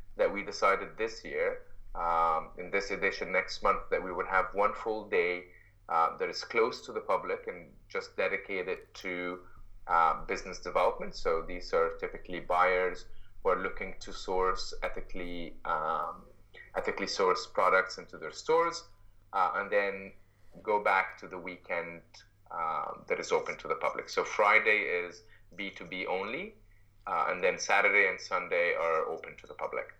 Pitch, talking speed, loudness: 115 Hz, 160 wpm, -31 LUFS